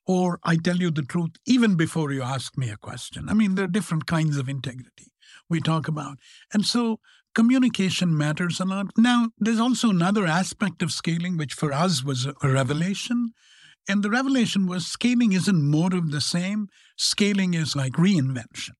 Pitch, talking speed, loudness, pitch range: 175 Hz, 180 wpm, -23 LUFS, 150-205 Hz